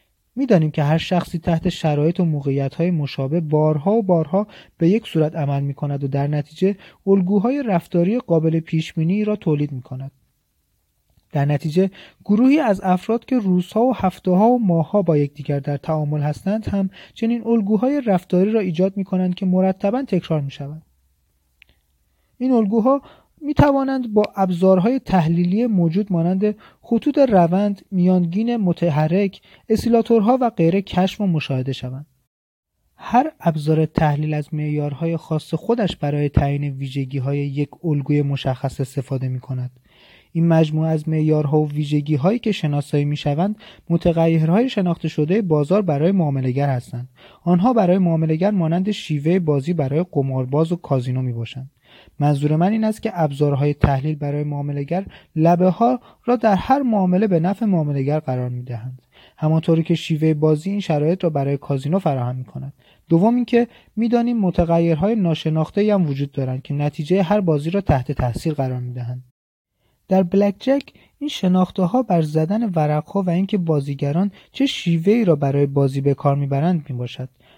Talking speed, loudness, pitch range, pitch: 160 wpm, -19 LUFS, 145-195 Hz, 165 Hz